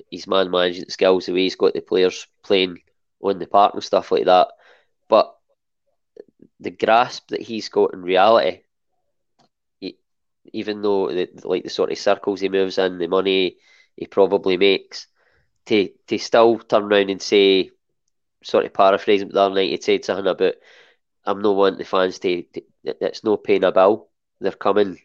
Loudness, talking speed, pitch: -19 LUFS, 180 wpm, 110 Hz